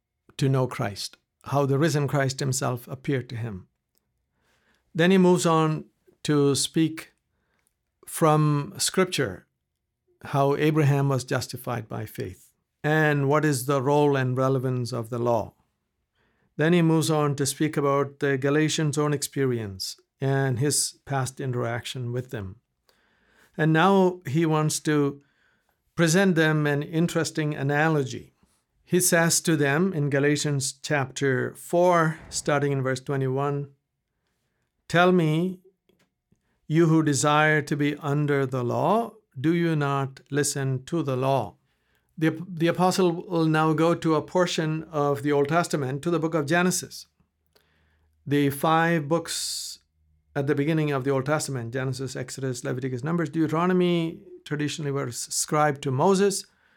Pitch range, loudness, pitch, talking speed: 135-160 Hz, -24 LUFS, 145 Hz, 135 wpm